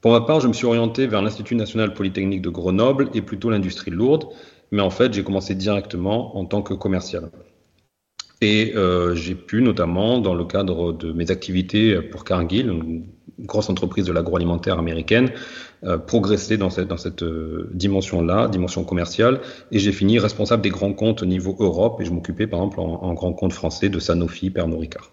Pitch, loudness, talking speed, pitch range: 95 Hz, -21 LUFS, 190 wpm, 90-110 Hz